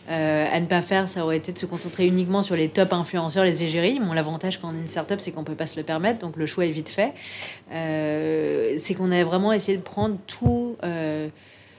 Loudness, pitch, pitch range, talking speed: -24 LUFS, 170 Hz, 160-190 Hz, 245 wpm